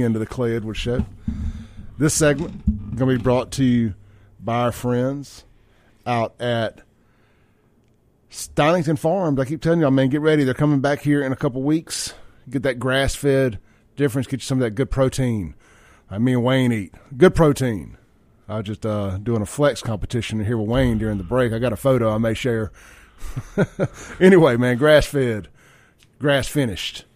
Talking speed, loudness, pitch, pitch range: 170 wpm, -20 LUFS, 125 Hz, 110-140 Hz